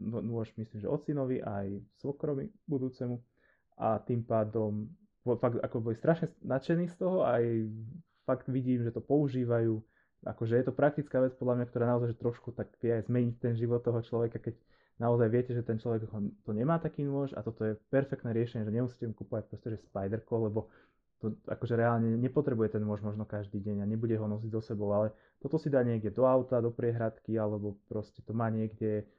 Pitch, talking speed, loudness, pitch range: 115 Hz, 195 wpm, -33 LUFS, 110-130 Hz